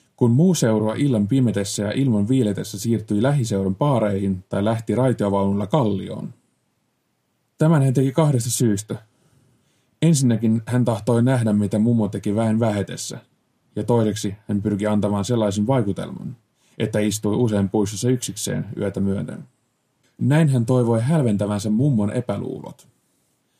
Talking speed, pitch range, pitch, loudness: 120 wpm, 105-130 Hz, 115 Hz, -21 LUFS